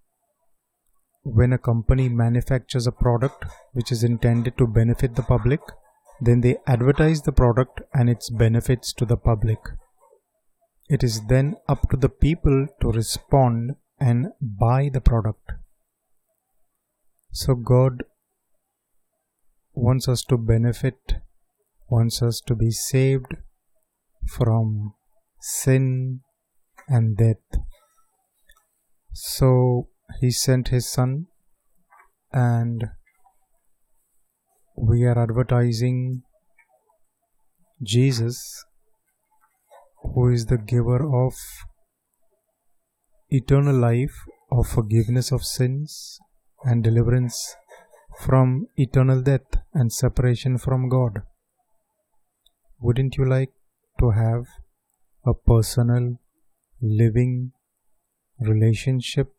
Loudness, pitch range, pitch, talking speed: -22 LUFS, 120-135 Hz, 125 Hz, 90 wpm